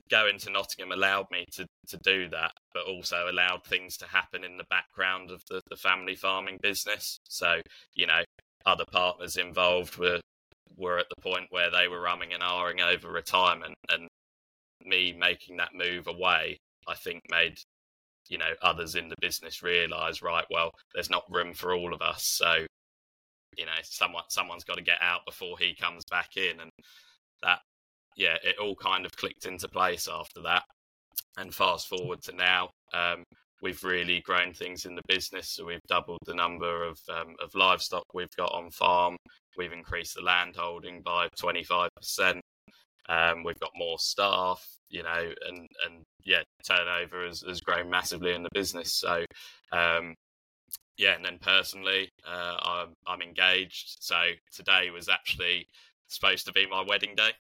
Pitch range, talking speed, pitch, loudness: 85-90 Hz, 170 wpm, 90 Hz, -28 LUFS